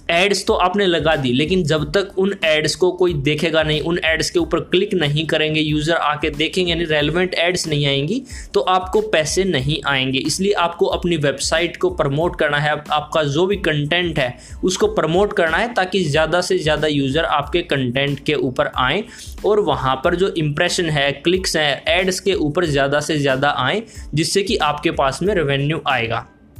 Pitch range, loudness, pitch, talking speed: 150-185 Hz, -18 LUFS, 165 Hz, 185 wpm